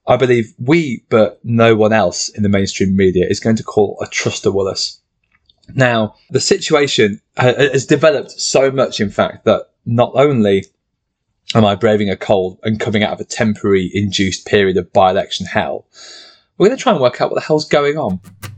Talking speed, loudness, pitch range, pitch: 195 wpm, -15 LUFS, 100-130 Hz, 110 Hz